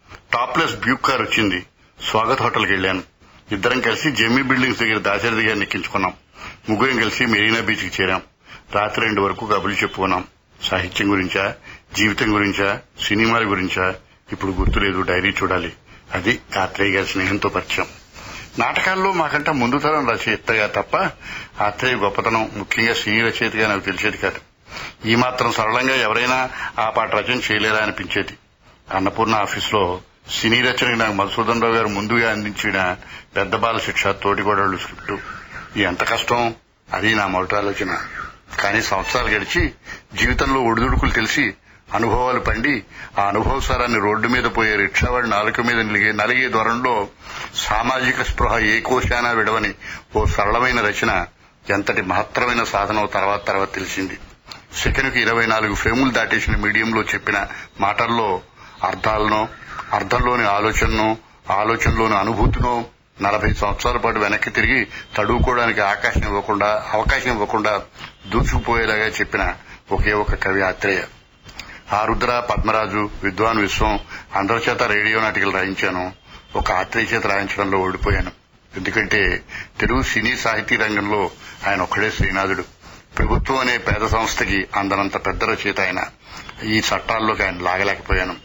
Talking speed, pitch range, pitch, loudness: 125 wpm, 100-115 Hz, 110 Hz, -19 LUFS